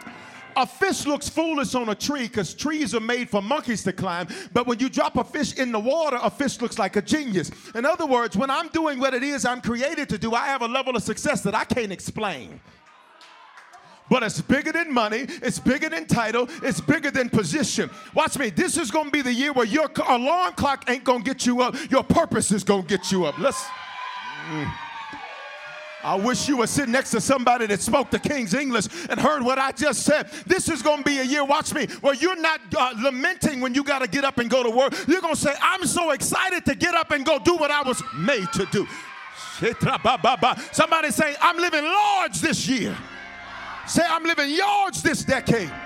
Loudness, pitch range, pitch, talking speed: -23 LUFS, 235-305 Hz, 270 Hz, 215 wpm